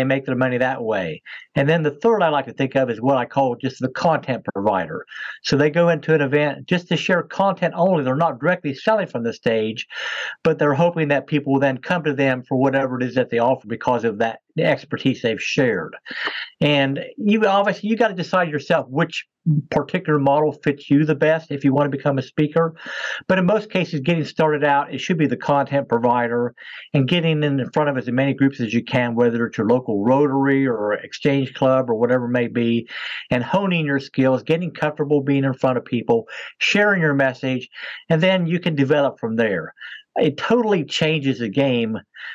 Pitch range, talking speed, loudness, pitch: 130-165 Hz, 210 wpm, -20 LUFS, 145 Hz